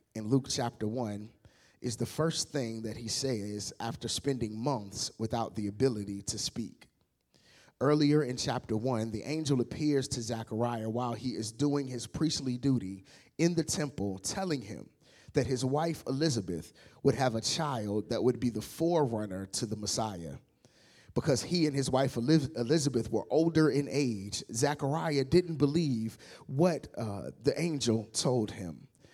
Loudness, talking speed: -32 LUFS, 155 wpm